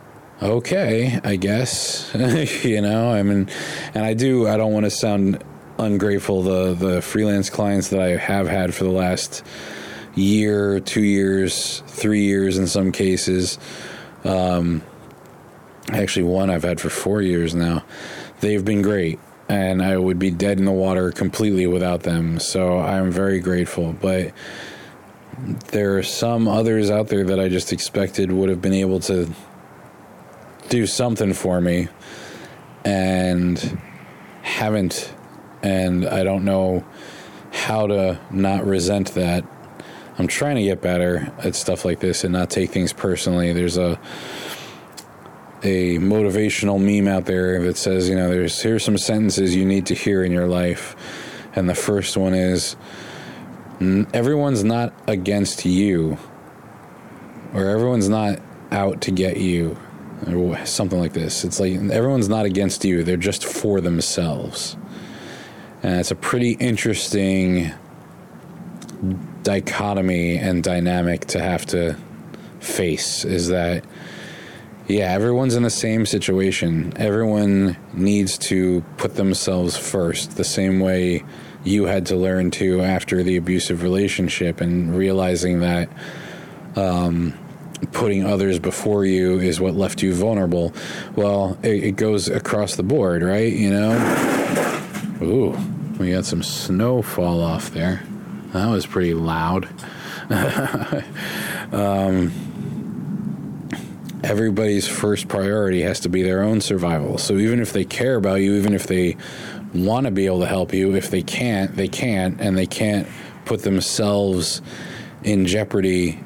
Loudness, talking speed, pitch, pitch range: -20 LUFS, 140 wpm, 95 Hz, 90-100 Hz